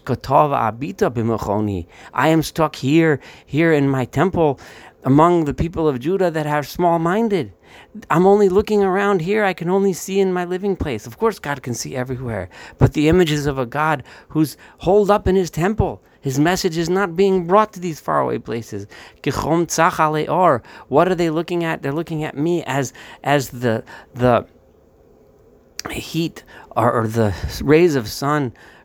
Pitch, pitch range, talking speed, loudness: 155 Hz, 130-180 Hz, 160 wpm, -19 LUFS